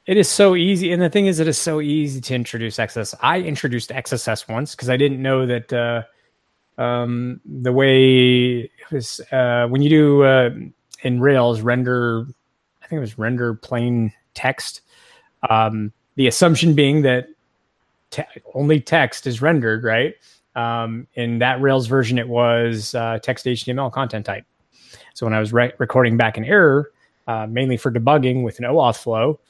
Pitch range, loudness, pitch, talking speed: 115-140 Hz, -18 LUFS, 125 Hz, 175 wpm